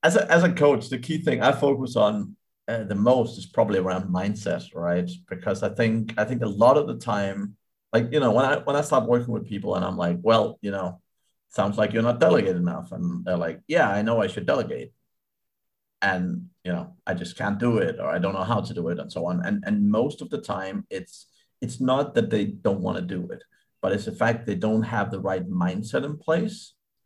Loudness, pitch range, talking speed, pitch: -24 LUFS, 105-160 Hz, 240 wpm, 120 Hz